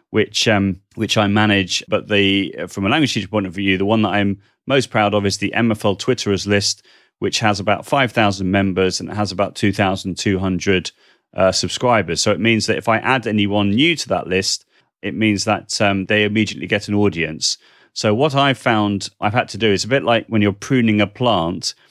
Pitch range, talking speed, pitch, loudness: 100-110 Hz, 210 wpm, 105 Hz, -18 LUFS